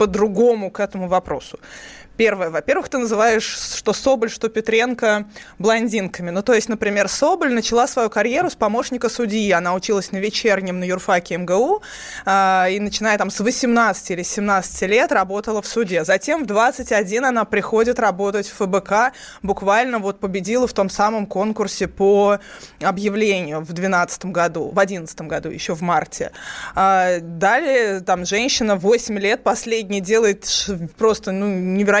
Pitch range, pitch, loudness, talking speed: 195-225 Hz, 205 Hz, -19 LUFS, 145 wpm